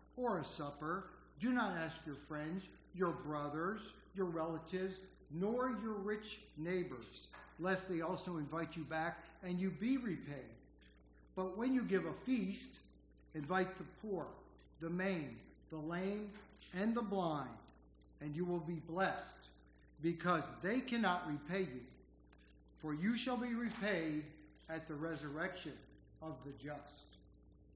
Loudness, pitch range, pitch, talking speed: -42 LUFS, 150-190 Hz, 170 Hz, 135 wpm